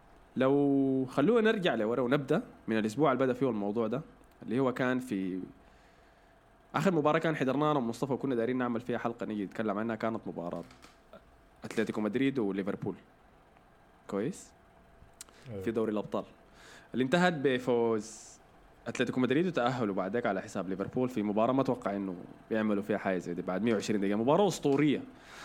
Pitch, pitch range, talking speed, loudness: 115 Hz, 100-135 Hz, 150 wpm, -31 LUFS